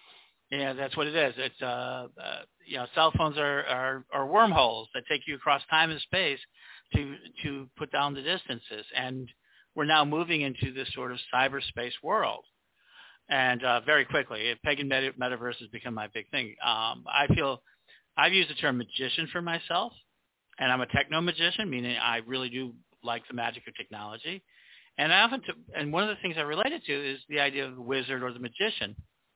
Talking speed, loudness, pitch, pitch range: 195 wpm, -29 LUFS, 135 Hz, 125-155 Hz